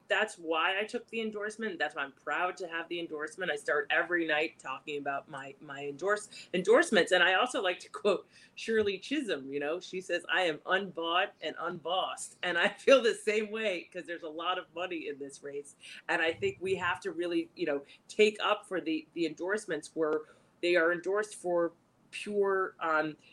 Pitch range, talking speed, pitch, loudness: 155-200 Hz, 200 wpm, 175 Hz, -32 LUFS